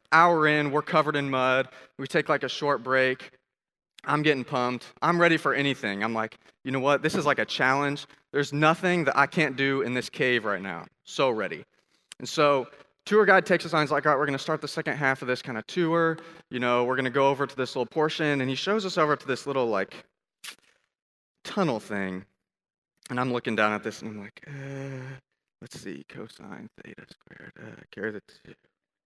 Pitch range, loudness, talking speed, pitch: 125-155 Hz, -25 LUFS, 220 wpm, 135 Hz